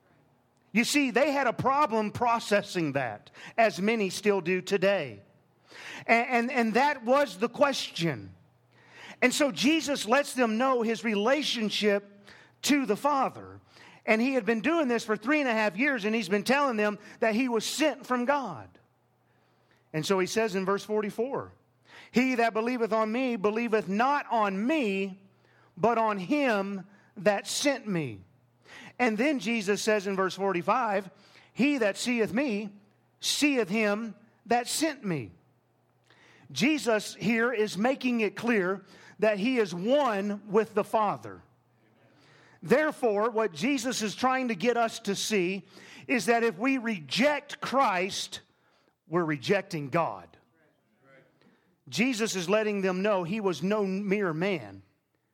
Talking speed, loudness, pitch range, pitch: 145 wpm, -28 LUFS, 190-245 Hz, 215 Hz